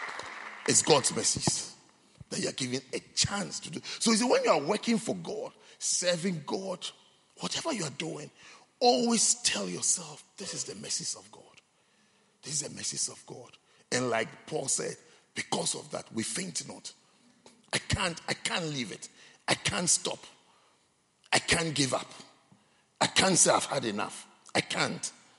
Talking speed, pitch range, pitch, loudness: 170 wpm, 165-235 Hz, 200 Hz, -29 LUFS